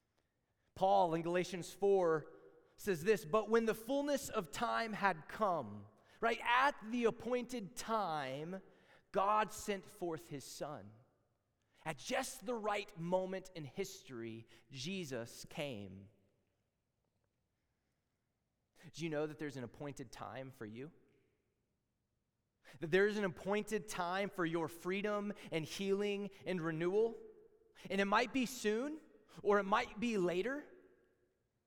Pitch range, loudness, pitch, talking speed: 135-215 Hz, -38 LUFS, 185 Hz, 125 wpm